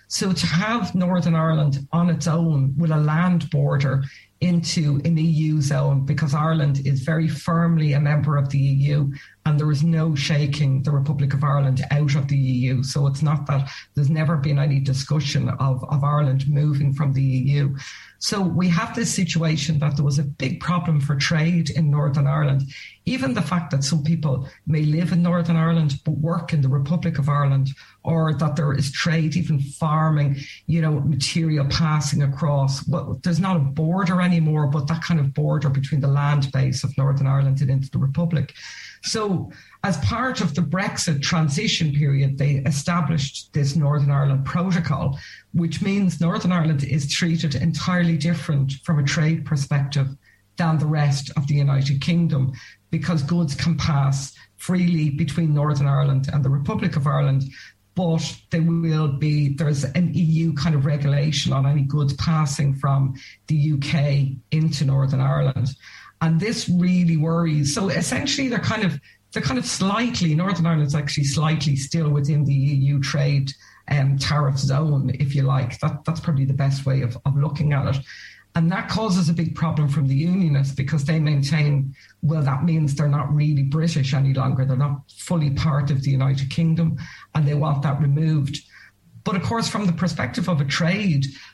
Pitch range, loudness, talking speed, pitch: 140-165 Hz, -21 LUFS, 180 wpm, 150 Hz